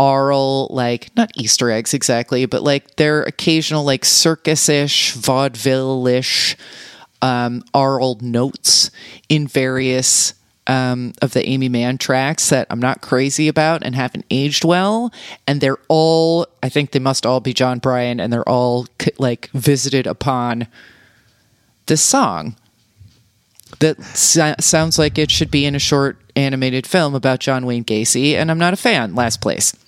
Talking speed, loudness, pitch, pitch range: 150 wpm, -16 LUFS, 135 Hz, 125-150 Hz